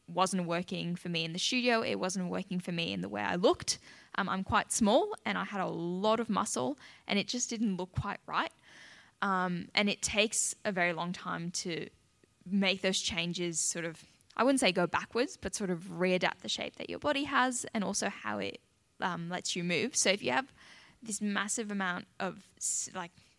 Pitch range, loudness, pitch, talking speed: 175-215 Hz, -32 LUFS, 185 Hz, 210 wpm